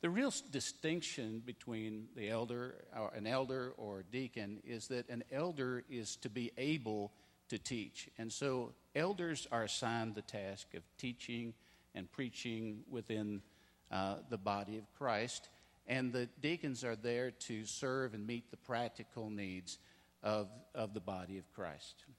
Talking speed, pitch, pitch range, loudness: 155 wpm, 115 Hz, 105-125 Hz, -43 LUFS